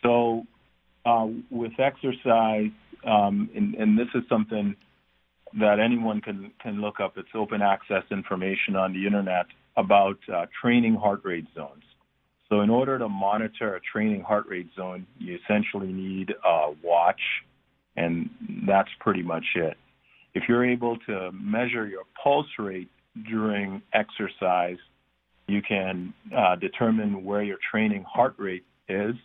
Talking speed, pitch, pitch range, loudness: 140 wpm, 105 Hz, 95-115 Hz, -26 LUFS